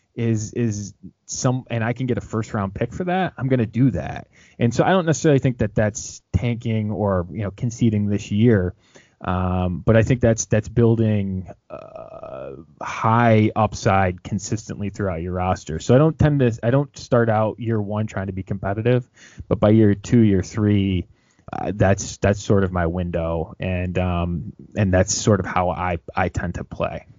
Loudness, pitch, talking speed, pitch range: -21 LUFS, 105 Hz, 190 wpm, 95-115 Hz